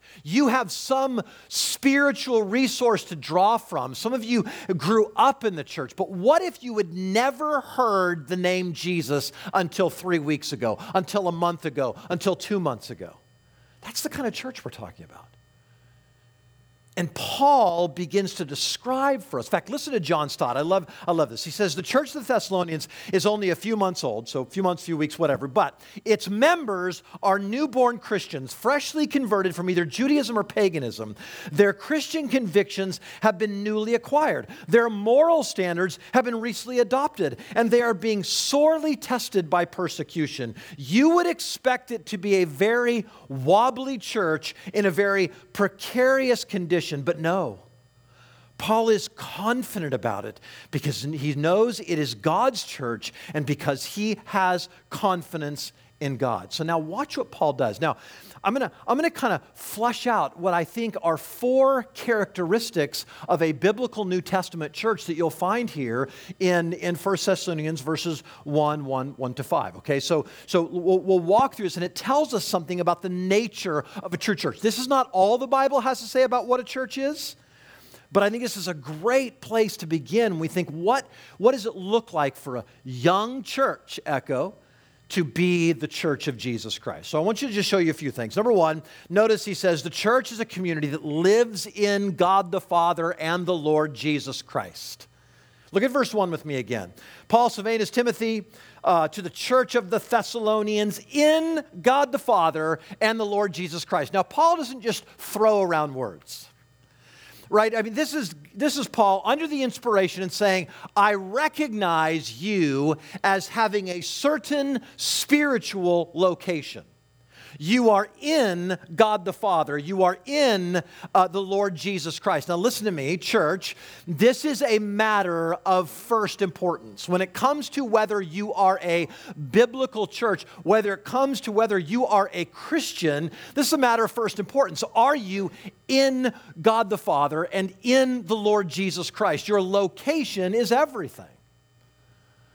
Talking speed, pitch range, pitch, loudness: 175 wpm, 165-230 Hz, 195 Hz, -24 LUFS